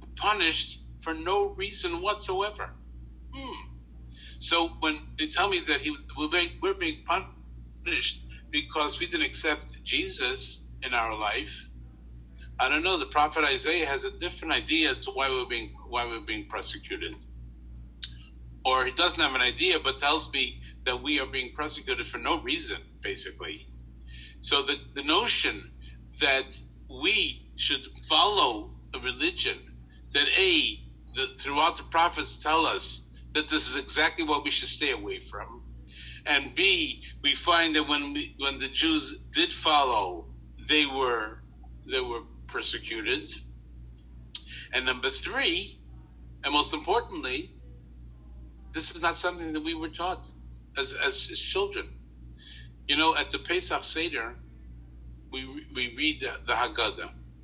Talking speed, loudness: 145 wpm, -27 LUFS